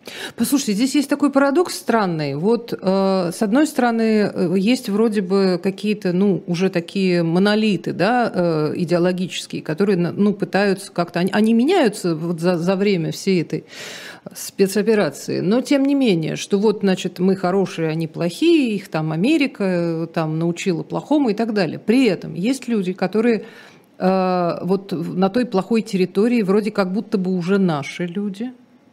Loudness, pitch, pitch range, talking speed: -19 LUFS, 195 Hz, 180-225 Hz, 155 wpm